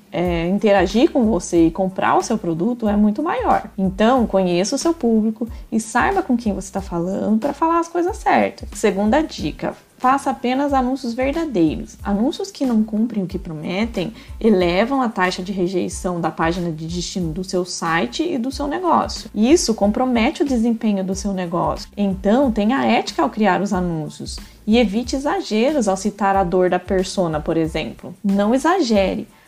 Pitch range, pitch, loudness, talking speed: 185-255 Hz, 205 Hz, -19 LUFS, 175 wpm